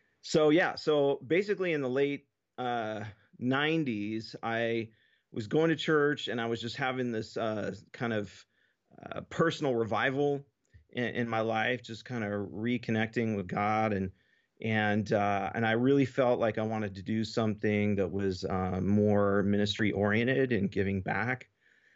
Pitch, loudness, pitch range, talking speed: 115 Hz, -30 LUFS, 105-130 Hz, 160 wpm